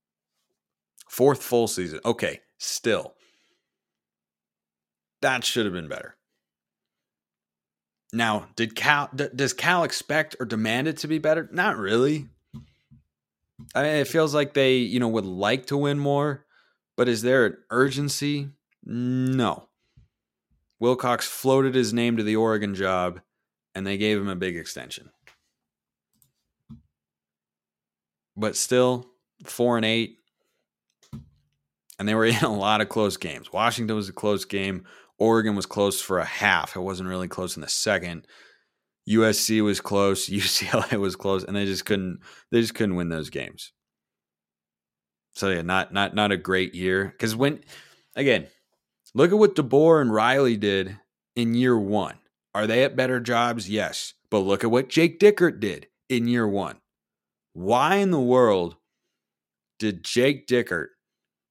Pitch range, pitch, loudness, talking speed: 90-125 Hz, 110 Hz, -24 LUFS, 145 wpm